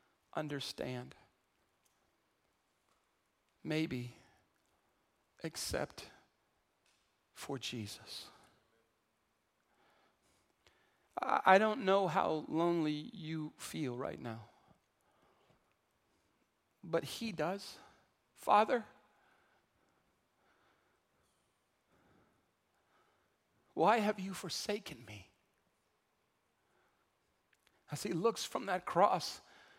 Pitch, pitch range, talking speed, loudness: 155 Hz, 125-190 Hz, 60 wpm, -36 LUFS